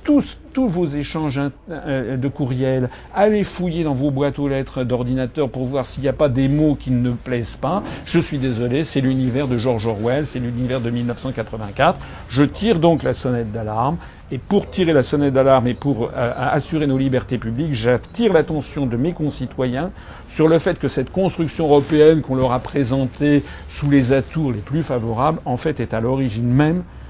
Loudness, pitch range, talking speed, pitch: -19 LUFS, 125-155 Hz, 190 wpm, 135 Hz